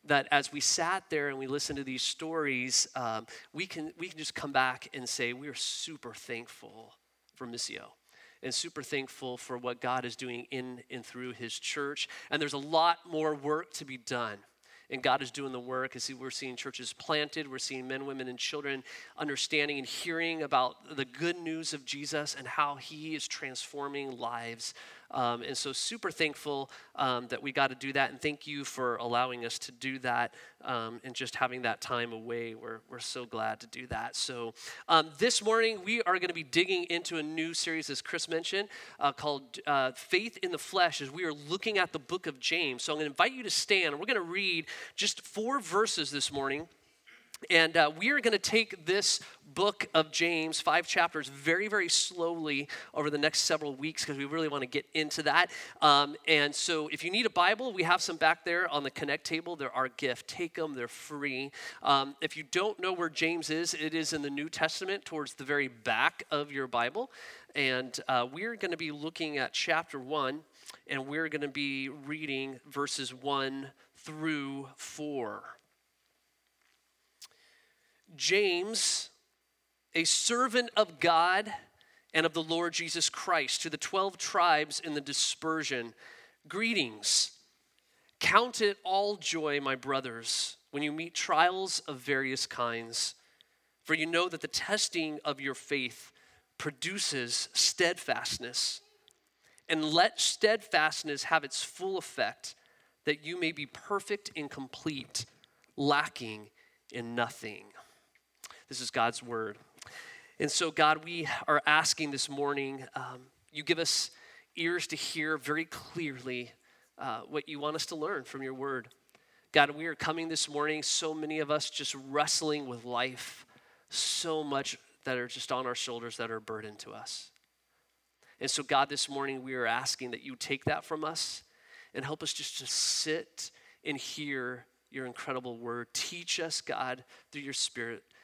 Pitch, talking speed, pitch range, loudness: 150 Hz, 180 wpm, 130-165 Hz, -32 LUFS